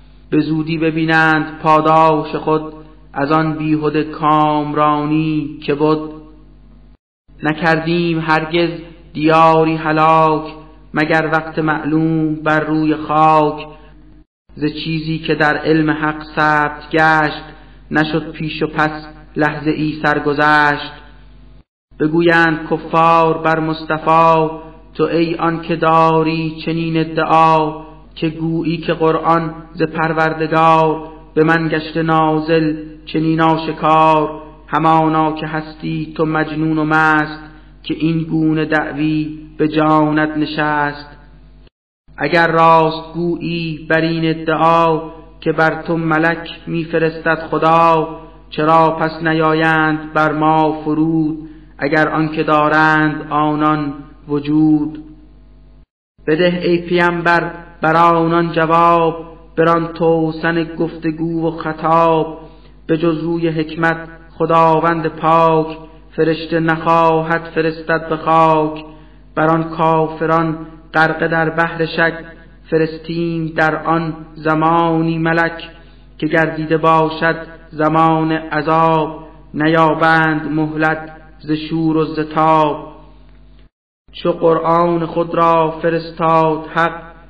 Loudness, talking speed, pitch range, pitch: -15 LUFS, 100 wpm, 155-165 Hz, 160 Hz